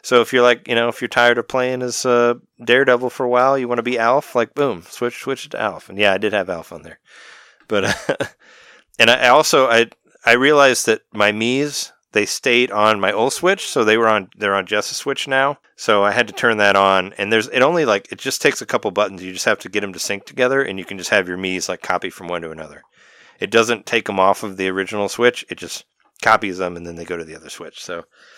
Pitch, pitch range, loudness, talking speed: 115 Hz, 100-125 Hz, -17 LUFS, 265 wpm